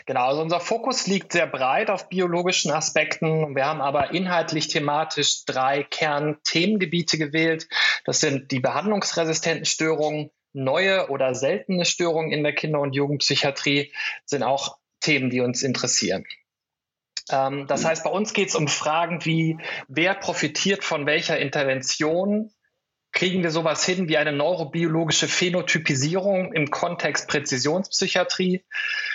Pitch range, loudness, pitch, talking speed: 145-180 Hz, -23 LUFS, 160 Hz, 130 wpm